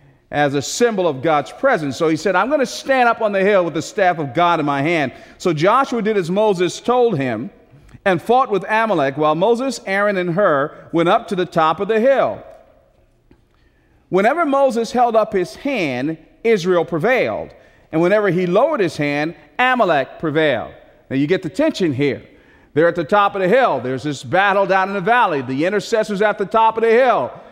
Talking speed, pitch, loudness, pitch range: 200 wpm, 190 Hz, -17 LUFS, 160-225 Hz